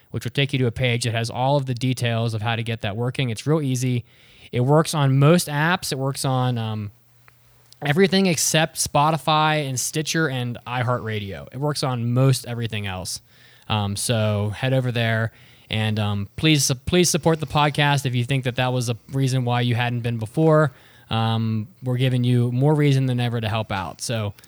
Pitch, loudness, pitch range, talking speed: 125 Hz, -22 LUFS, 115-140 Hz, 200 wpm